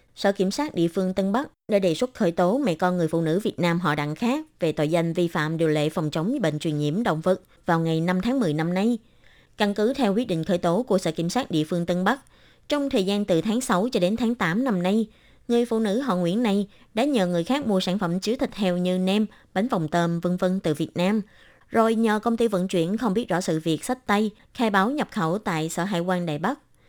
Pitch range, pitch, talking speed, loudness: 170-225 Hz, 185 Hz, 265 wpm, -24 LUFS